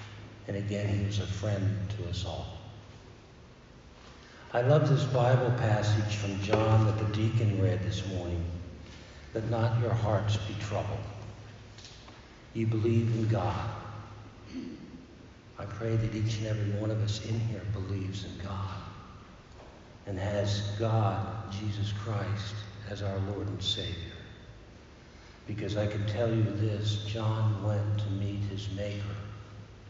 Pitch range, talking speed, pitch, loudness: 100-110 Hz, 135 wpm, 105 Hz, -31 LUFS